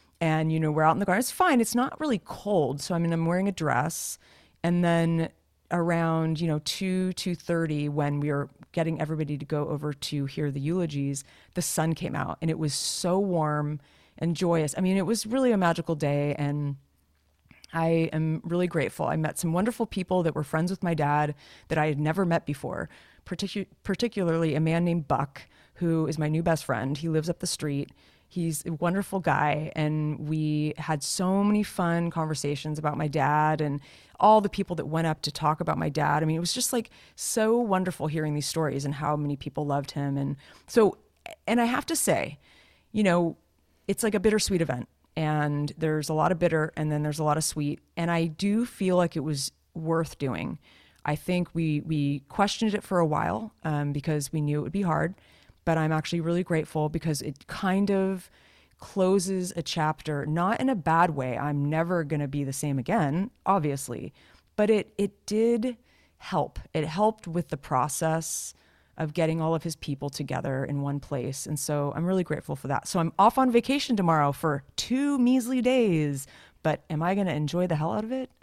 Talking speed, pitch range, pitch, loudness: 205 wpm, 150-185 Hz, 160 Hz, -27 LUFS